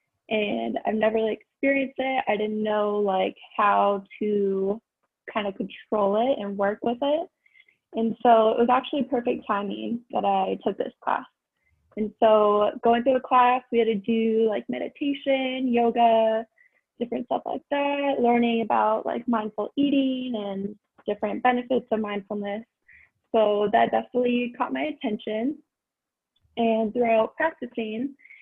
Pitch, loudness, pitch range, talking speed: 230 Hz, -25 LUFS, 210-260 Hz, 145 wpm